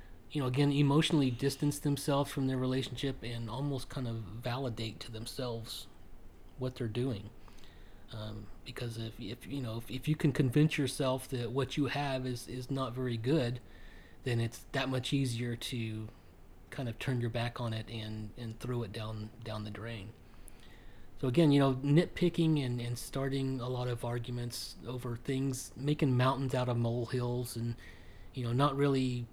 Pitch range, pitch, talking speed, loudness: 115-135 Hz, 125 Hz, 175 wpm, -34 LUFS